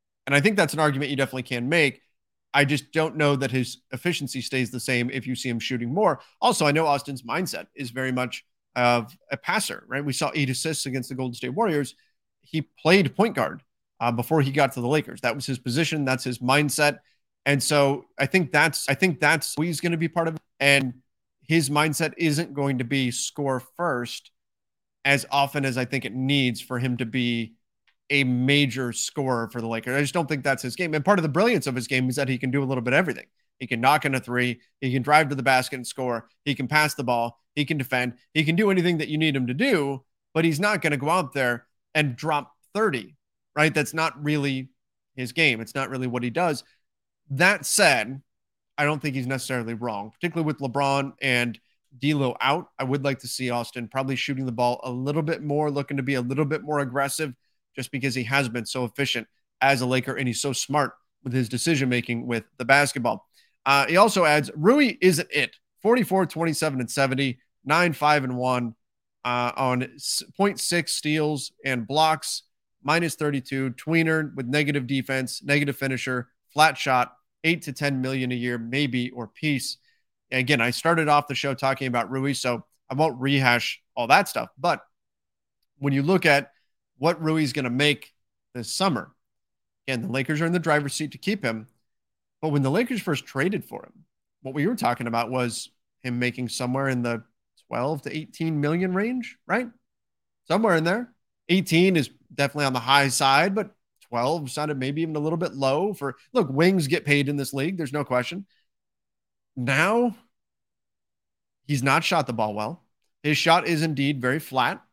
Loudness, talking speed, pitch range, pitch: -24 LUFS, 205 wpm, 125-155 Hz, 140 Hz